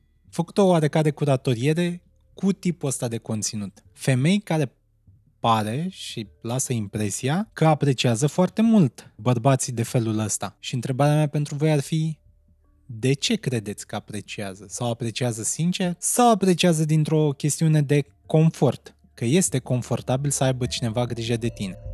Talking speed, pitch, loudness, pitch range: 145 wpm, 130 Hz, -23 LUFS, 115-155 Hz